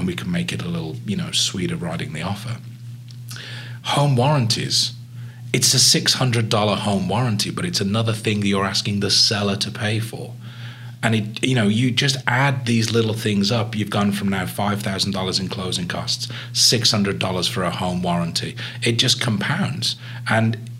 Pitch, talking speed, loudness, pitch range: 115 Hz, 190 wpm, -20 LUFS, 105-120 Hz